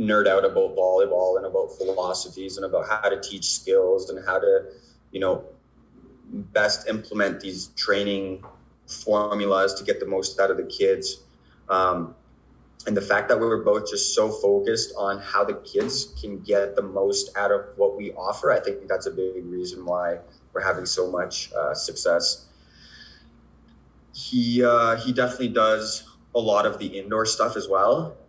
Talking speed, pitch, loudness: 170 wpm, 125 Hz, -23 LUFS